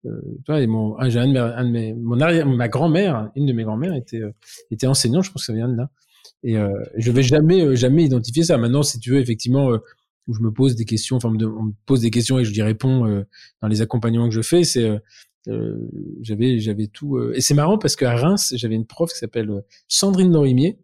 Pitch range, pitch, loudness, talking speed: 115-145 Hz, 125 Hz, -19 LUFS, 245 wpm